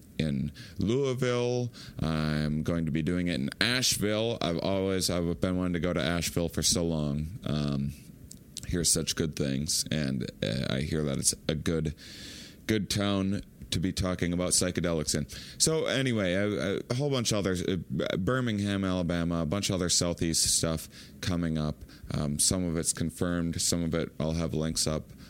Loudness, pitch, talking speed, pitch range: -29 LUFS, 85 Hz, 170 wpm, 80-100 Hz